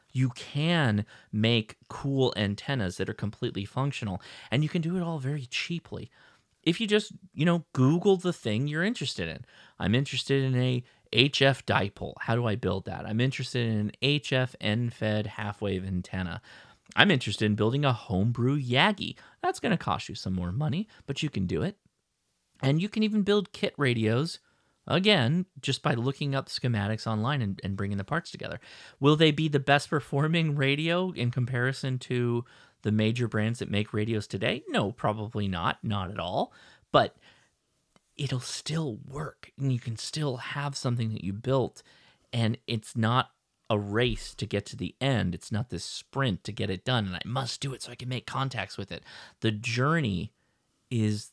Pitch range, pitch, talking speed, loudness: 105-140 Hz, 125 Hz, 185 wpm, -29 LUFS